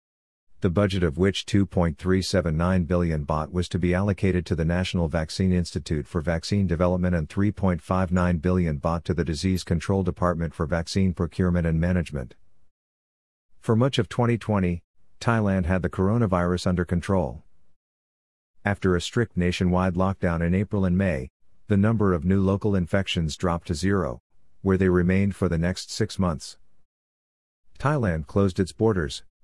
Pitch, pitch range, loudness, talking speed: 90 Hz, 85-95 Hz, -24 LUFS, 150 wpm